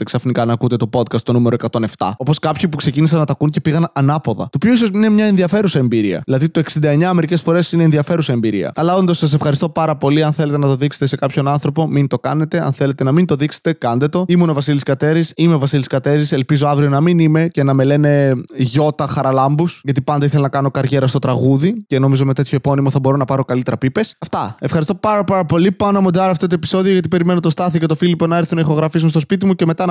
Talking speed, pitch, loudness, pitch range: 245 wpm, 150 Hz, -15 LUFS, 135-170 Hz